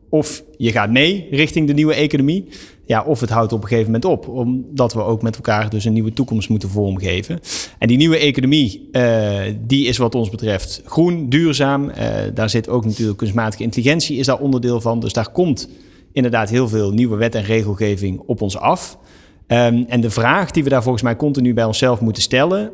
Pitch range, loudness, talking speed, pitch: 110-140 Hz, -17 LUFS, 205 wpm, 120 Hz